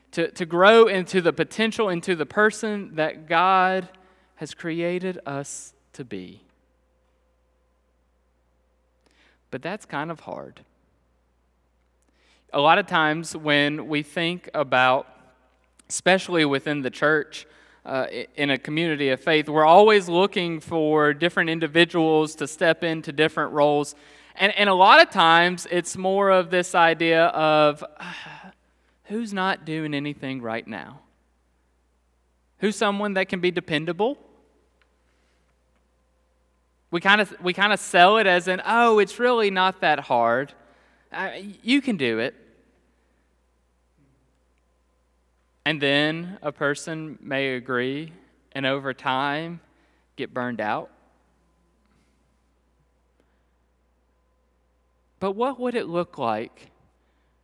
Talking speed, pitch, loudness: 115 wpm, 150 Hz, -21 LUFS